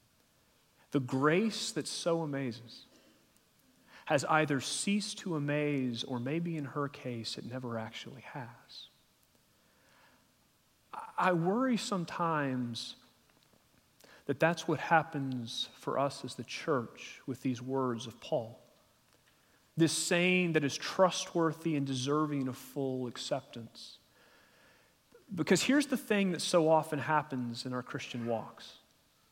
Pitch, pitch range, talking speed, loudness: 145 Hz, 130-165 Hz, 120 wpm, -33 LUFS